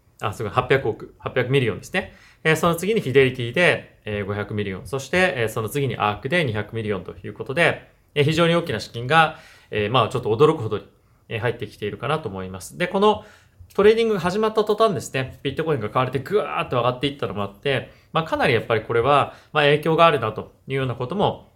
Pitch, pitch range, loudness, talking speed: 130 Hz, 105-160 Hz, -22 LUFS, 430 characters per minute